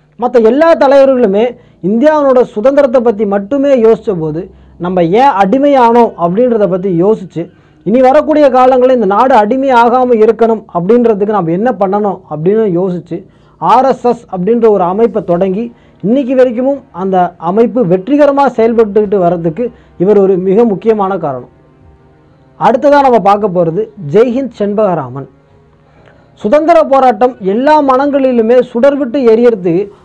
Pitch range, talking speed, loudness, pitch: 190-255 Hz, 115 wpm, -9 LUFS, 225 Hz